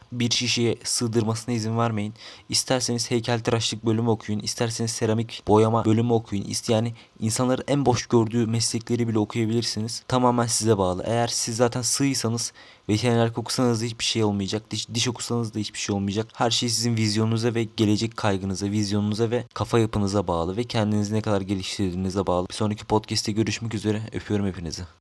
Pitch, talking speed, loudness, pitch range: 115 Hz, 165 wpm, -24 LUFS, 105-120 Hz